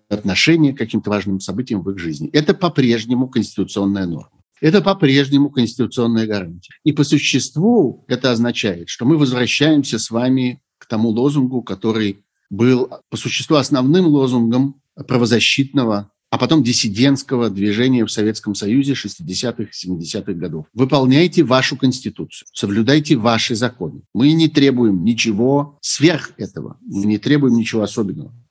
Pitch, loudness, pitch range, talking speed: 120 Hz, -17 LUFS, 105-140 Hz, 135 wpm